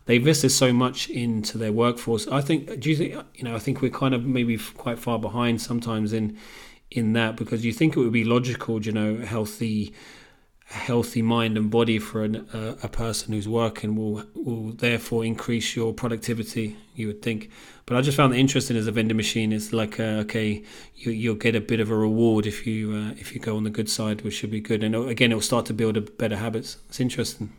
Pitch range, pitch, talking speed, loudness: 110-120 Hz, 115 Hz, 230 wpm, -25 LUFS